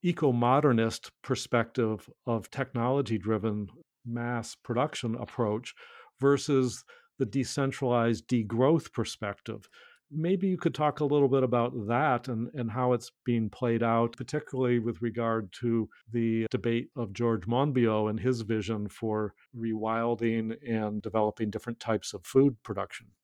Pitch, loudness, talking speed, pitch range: 120 Hz, -30 LUFS, 130 wpm, 115-130 Hz